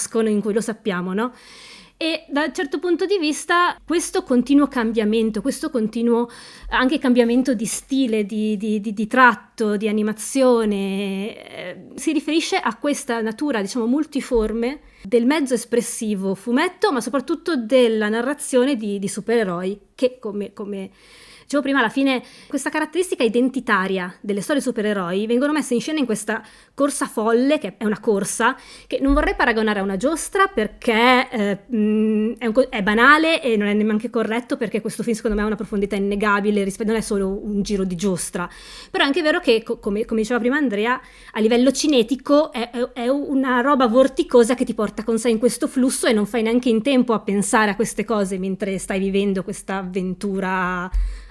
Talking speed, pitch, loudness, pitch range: 175 wpm, 235 Hz, -20 LUFS, 210-265 Hz